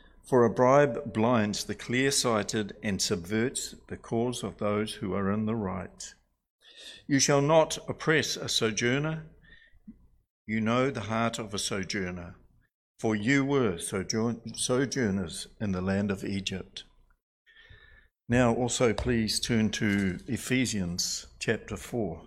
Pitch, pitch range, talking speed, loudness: 110 Hz, 100-125 Hz, 130 wpm, -28 LUFS